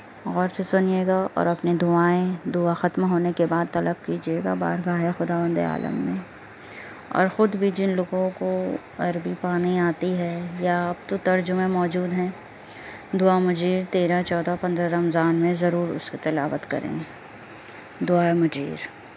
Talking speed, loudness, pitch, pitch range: 145 wpm, -24 LUFS, 175 Hz, 170-185 Hz